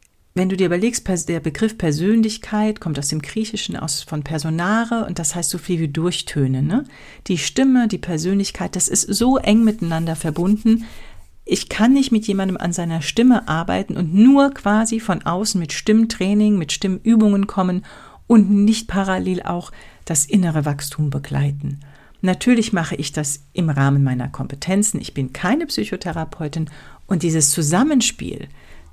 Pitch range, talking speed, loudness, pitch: 160-215 Hz, 155 wpm, -19 LUFS, 185 Hz